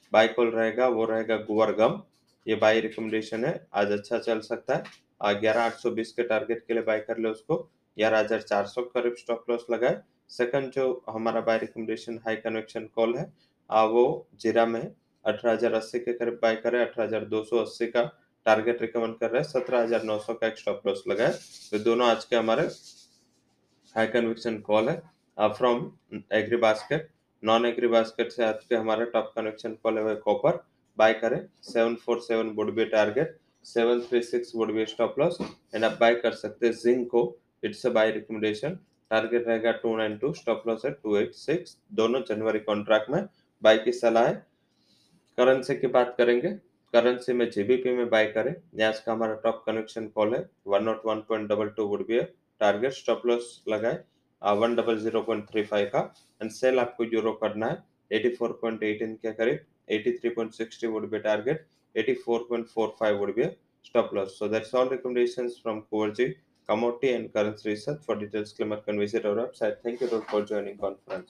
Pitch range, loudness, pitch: 110-120 Hz, -27 LUFS, 115 Hz